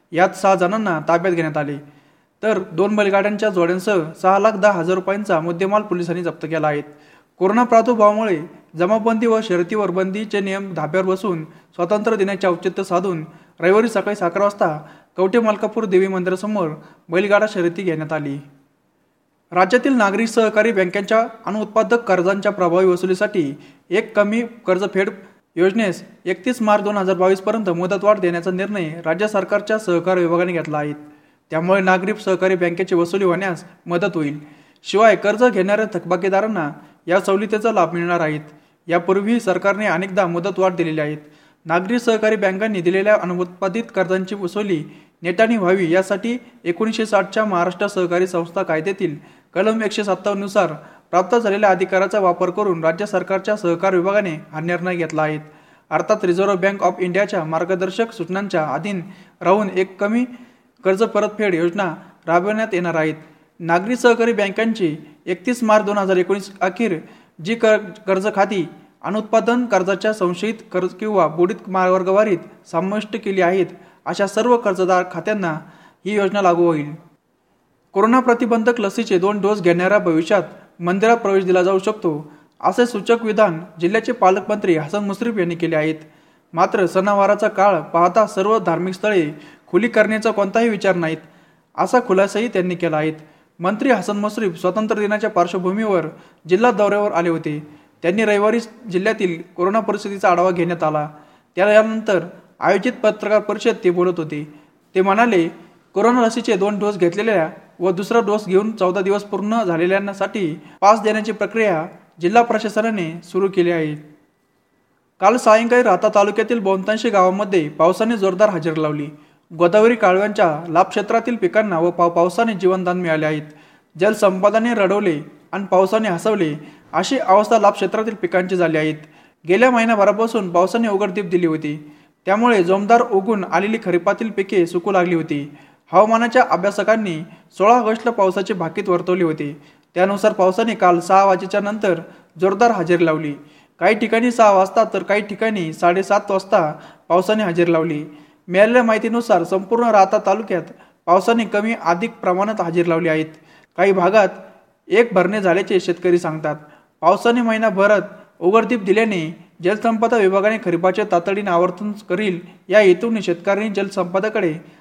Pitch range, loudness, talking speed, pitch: 175-210 Hz, -18 LUFS, 130 wpm, 190 Hz